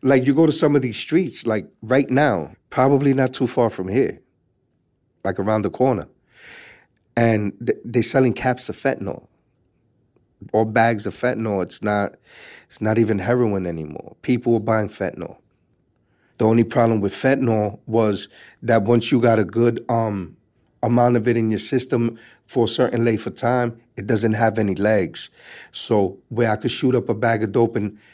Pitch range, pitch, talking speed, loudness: 105-125 Hz, 115 Hz, 175 wpm, -20 LUFS